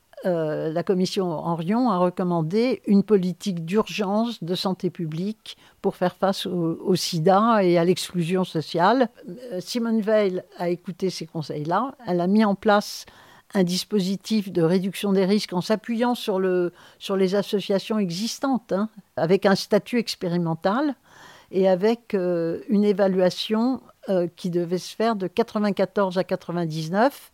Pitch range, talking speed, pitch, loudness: 180-215 Hz, 145 wpm, 190 Hz, -23 LUFS